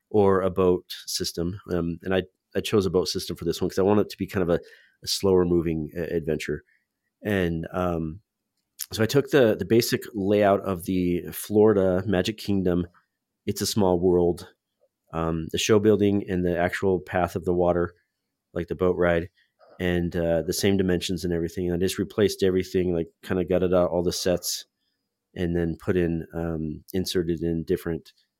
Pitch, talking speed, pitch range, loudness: 90 Hz, 190 wpm, 85-95 Hz, -25 LUFS